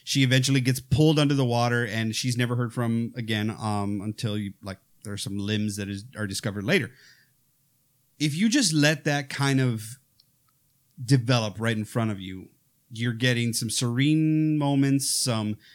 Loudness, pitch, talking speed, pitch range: -25 LUFS, 125 Hz, 170 wpm, 110-140 Hz